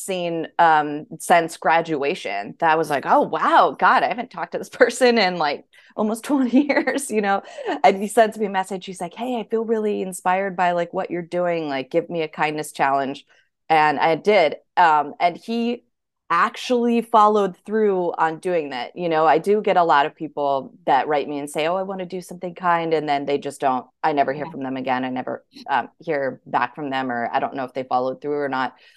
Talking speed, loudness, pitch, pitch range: 225 wpm, -21 LUFS, 170 Hz, 145-205 Hz